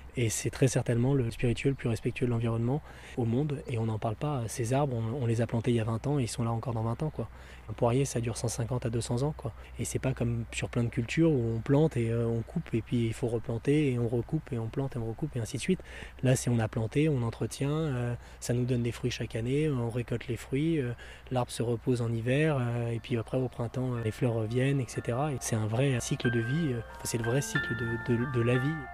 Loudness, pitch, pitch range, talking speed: -31 LUFS, 120 Hz, 115-135 Hz, 265 wpm